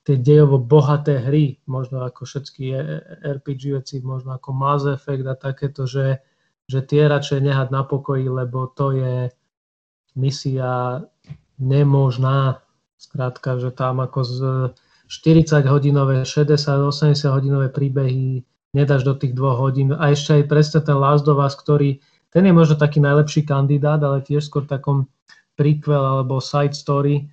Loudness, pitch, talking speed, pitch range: -18 LUFS, 140 Hz, 145 wpm, 130-145 Hz